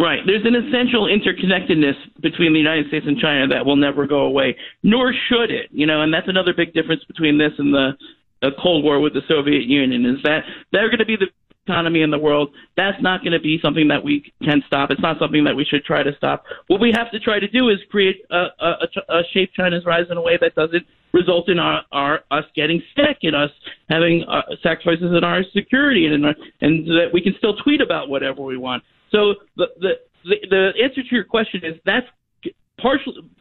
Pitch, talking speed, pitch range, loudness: 170 Hz, 230 wpm, 150-200 Hz, -18 LUFS